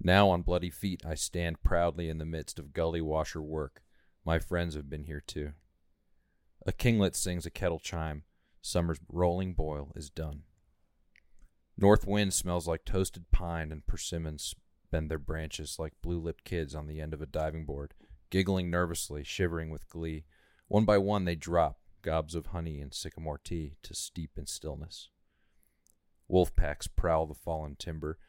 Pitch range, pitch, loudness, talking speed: 75-90 Hz, 80 Hz, -33 LUFS, 170 wpm